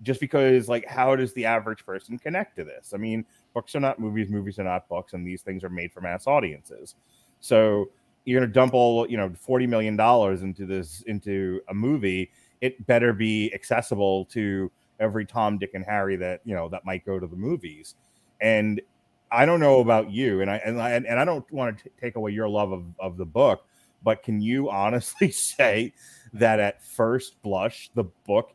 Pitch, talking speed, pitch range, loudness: 110 Hz, 205 wpm, 95-125 Hz, -25 LUFS